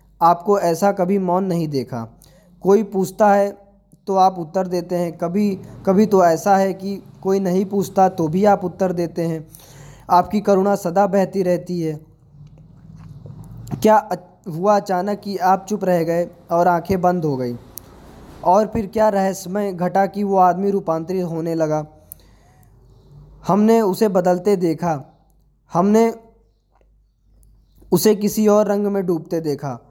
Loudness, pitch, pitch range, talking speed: -18 LUFS, 180 Hz, 160-200 Hz, 140 wpm